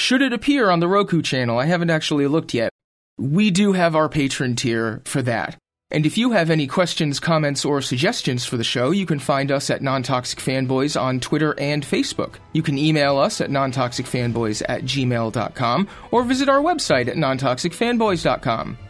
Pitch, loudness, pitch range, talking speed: 150 Hz, -20 LUFS, 130-175 Hz, 180 wpm